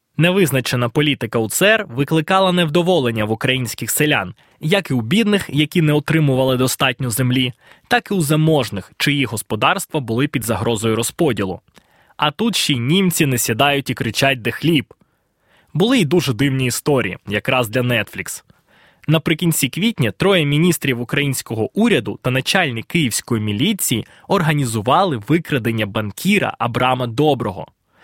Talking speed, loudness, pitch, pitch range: 130 wpm, -17 LUFS, 140 Hz, 120-165 Hz